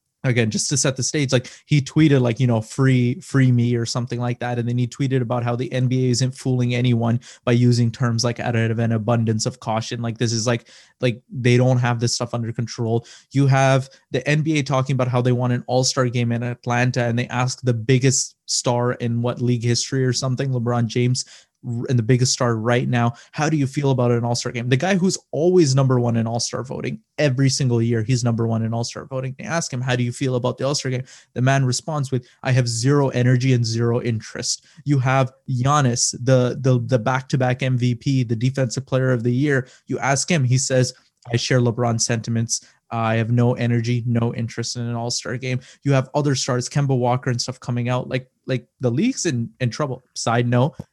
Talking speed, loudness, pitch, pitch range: 220 wpm, -21 LUFS, 125 Hz, 120-130 Hz